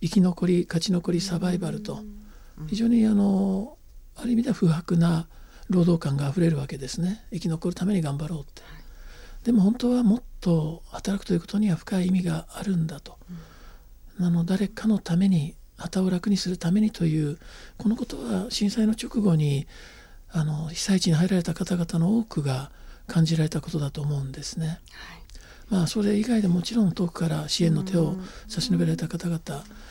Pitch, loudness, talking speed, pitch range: 180 Hz, -25 LUFS, 345 characters per minute, 165-200 Hz